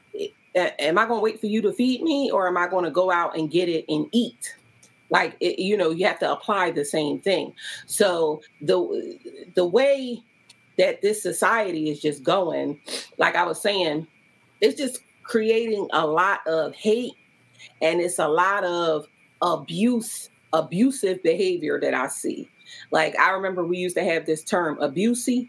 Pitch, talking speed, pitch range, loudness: 195 Hz, 180 wpm, 165-245 Hz, -23 LUFS